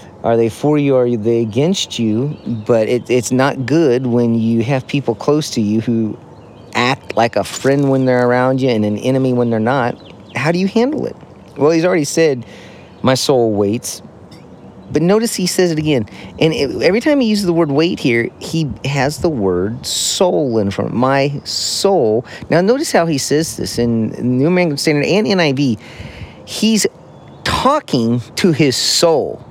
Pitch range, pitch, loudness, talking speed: 115-160 Hz, 130 Hz, -15 LUFS, 180 wpm